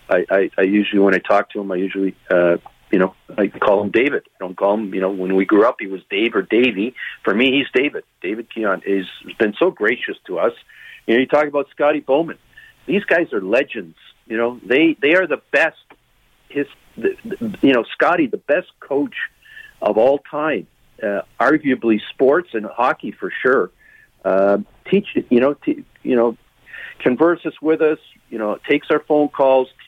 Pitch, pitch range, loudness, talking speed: 130 Hz, 100-150 Hz, -18 LUFS, 200 wpm